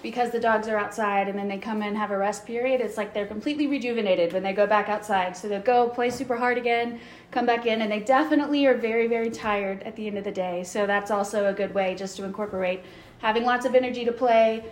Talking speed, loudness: 255 wpm, -25 LUFS